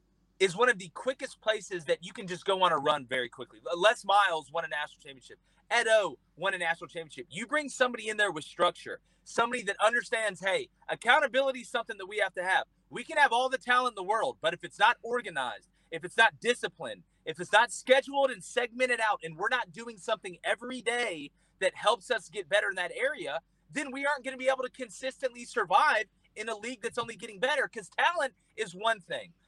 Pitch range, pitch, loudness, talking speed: 180-255 Hz, 225 Hz, -30 LUFS, 220 wpm